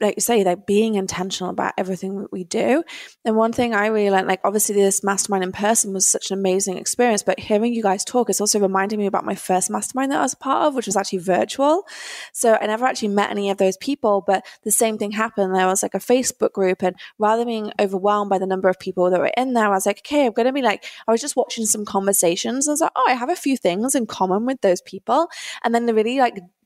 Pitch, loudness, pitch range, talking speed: 210 Hz, -20 LUFS, 195-235 Hz, 265 wpm